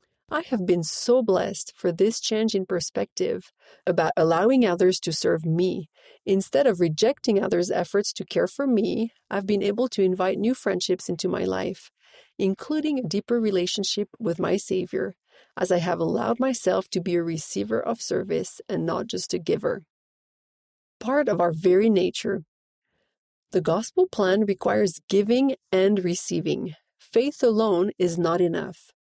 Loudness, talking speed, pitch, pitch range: -24 LUFS, 155 wpm, 195 Hz, 180-225 Hz